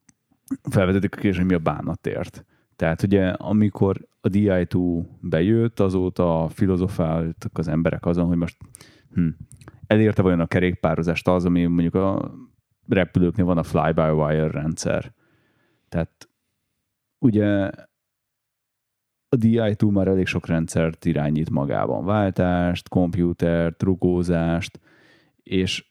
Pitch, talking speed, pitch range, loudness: 90 Hz, 115 wpm, 85-105 Hz, -22 LUFS